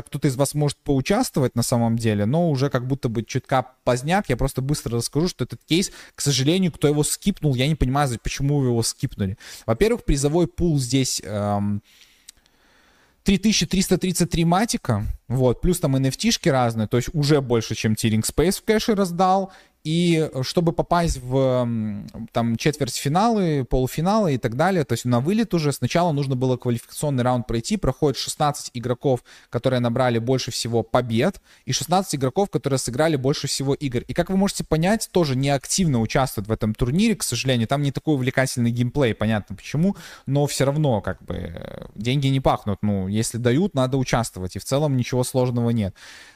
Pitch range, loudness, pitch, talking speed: 120-160 Hz, -22 LUFS, 135 Hz, 170 wpm